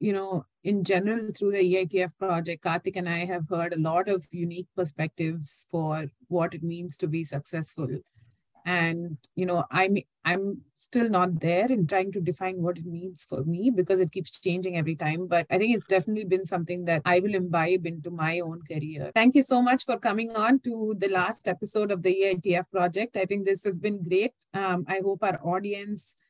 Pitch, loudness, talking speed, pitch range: 180 Hz, -27 LUFS, 205 wpm, 170-195 Hz